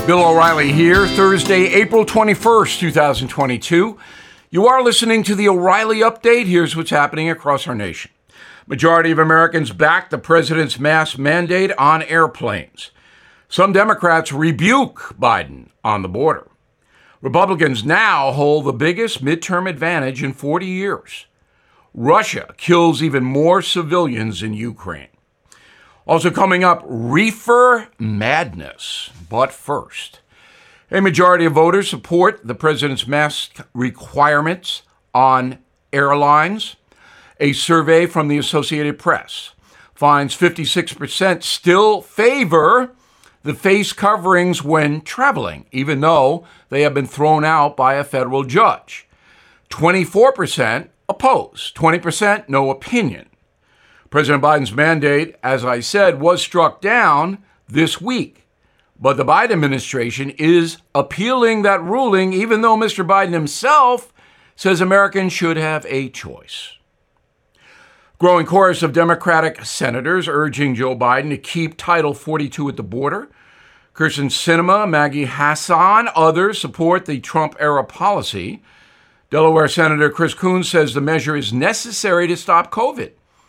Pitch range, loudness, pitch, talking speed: 145-185 Hz, -15 LUFS, 160 Hz, 120 wpm